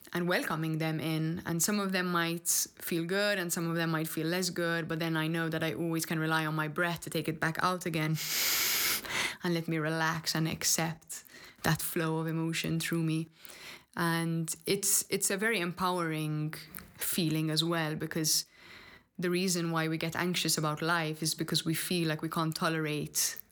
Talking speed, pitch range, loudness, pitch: 190 wpm, 160-175 Hz, -31 LUFS, 165 Hz